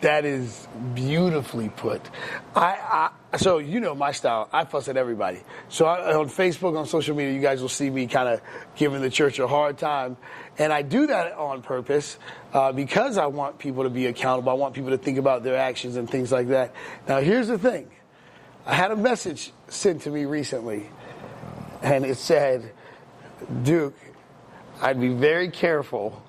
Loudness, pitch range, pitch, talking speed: -24 LUFS, 130-155 Hz, 140 Hz, 185 wpm